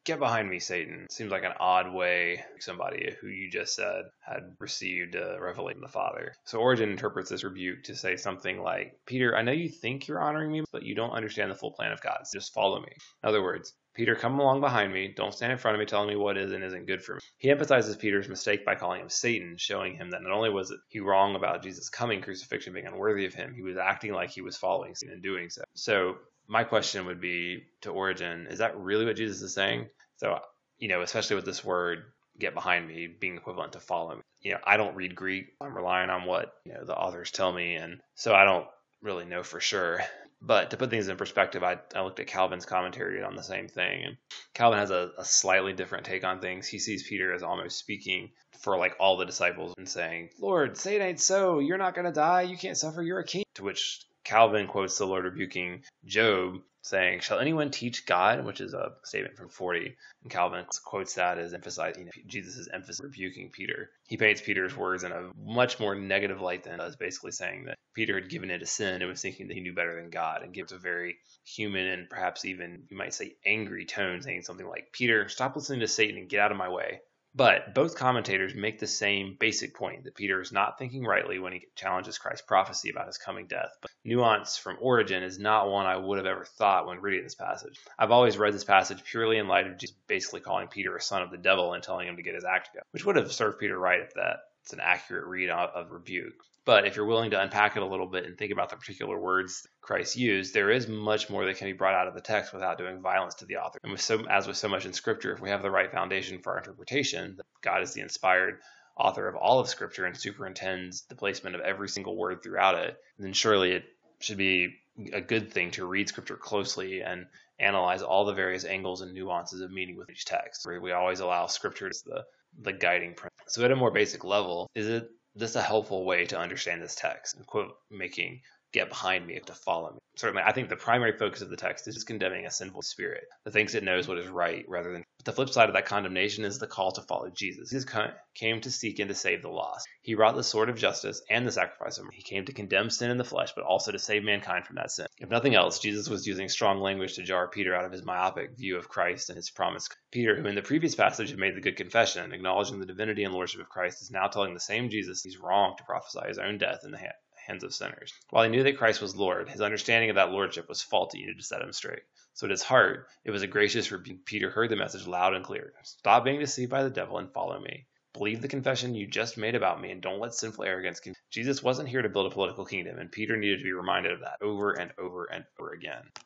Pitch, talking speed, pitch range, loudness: 100 Hz, 250 wpm, 90-115 Hz, -29 LUFS